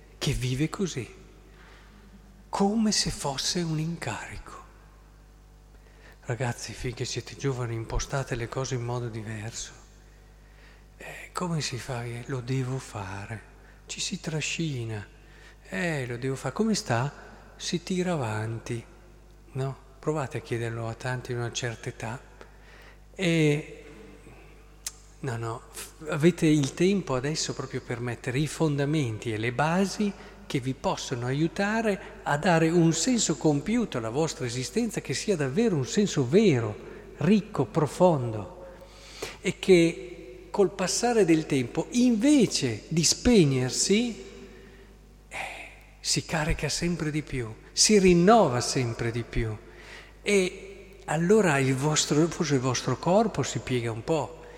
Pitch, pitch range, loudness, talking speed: 150 Hz, 125-180 Hz, -27 LUFS, 130 wpm